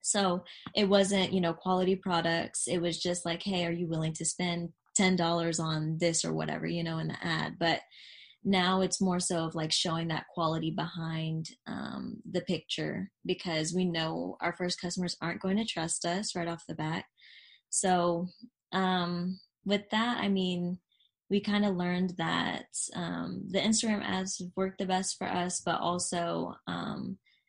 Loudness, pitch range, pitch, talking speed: -31 LUFS, 165-190 Hz, 180 Hz, 170 wpm